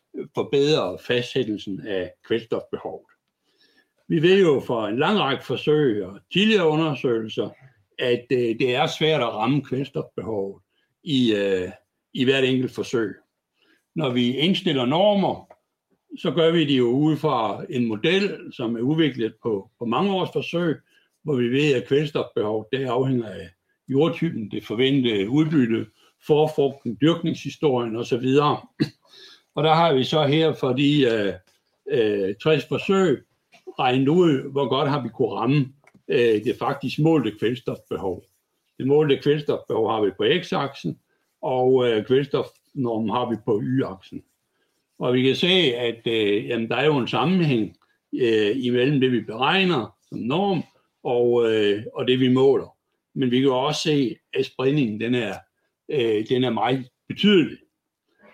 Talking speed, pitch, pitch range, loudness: 145 wpm, 130 Hz, 120-155 Hz, -22 LUFS